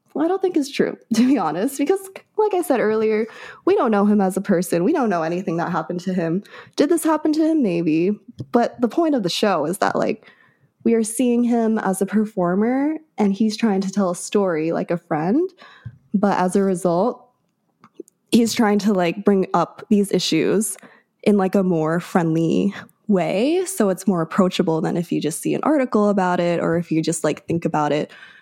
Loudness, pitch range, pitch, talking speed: -20 LUFS, 175-240 Hz, 205 Hz, 210 wpm